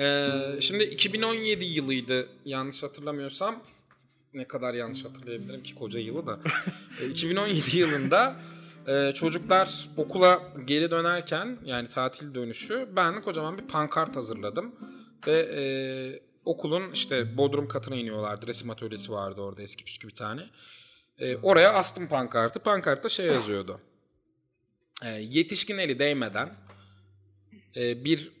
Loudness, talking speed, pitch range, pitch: -28 LUFS, 125 wpm, 120-175 Hz, 140 Hz